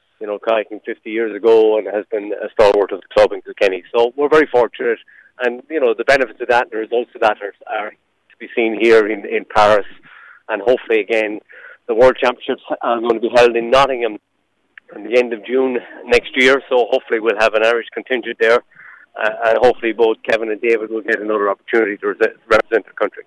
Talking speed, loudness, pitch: 215 wpm, -16 LUFS, 120 Hz